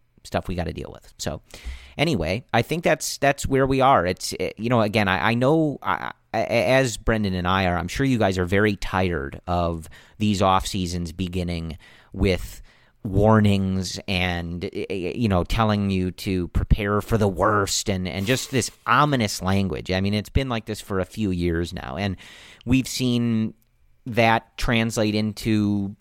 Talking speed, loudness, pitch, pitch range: 175 wpm, -23 LUFS, 100 Hz, 90-115 Hz